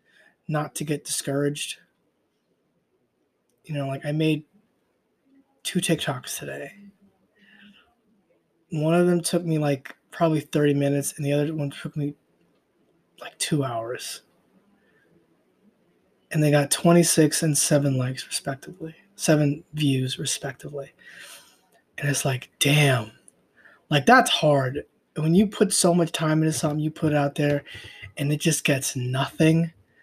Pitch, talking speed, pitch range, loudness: 150 Hz, 130 wpm, 140-170 Hz, -23 LUFS